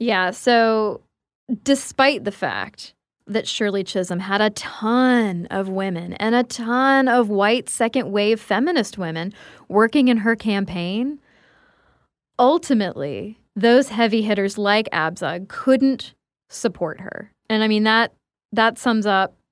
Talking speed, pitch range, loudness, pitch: 130 wpm, 195-240 Hz, -20 LUFS, 220 Hz